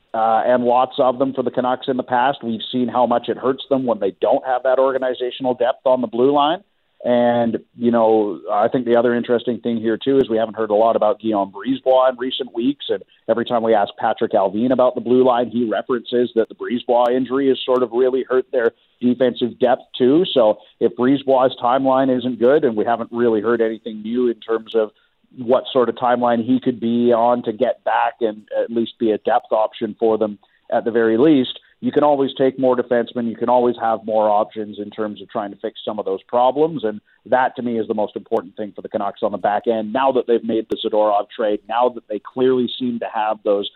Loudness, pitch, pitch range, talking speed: -19 LUFS, 120 Hz, 110-130 Hz, 235 wpm